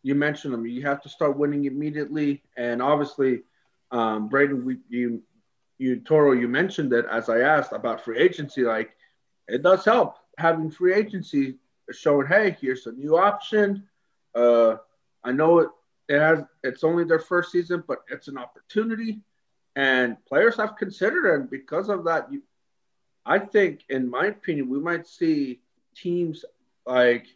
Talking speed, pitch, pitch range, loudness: 160 wpm, 145 Hz, 130-180 Hz, -23 LUFS